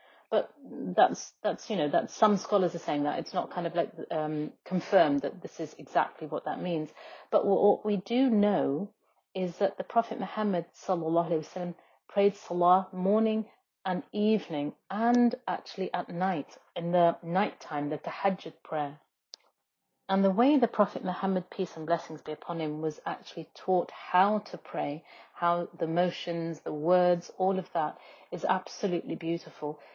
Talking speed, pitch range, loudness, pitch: 160 wpm, 165-200 Hz, -30 LUFS, 180 Hz